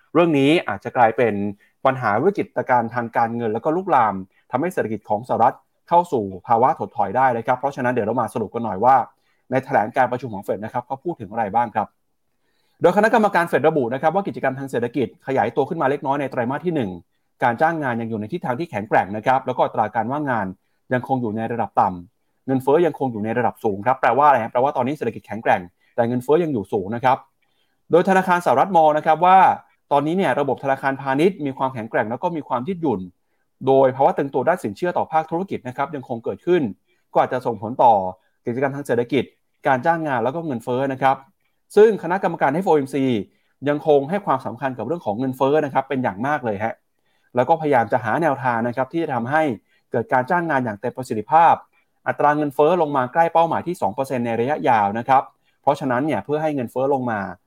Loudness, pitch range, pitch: -20 LUFS, 120-160 Hz, 135 Hz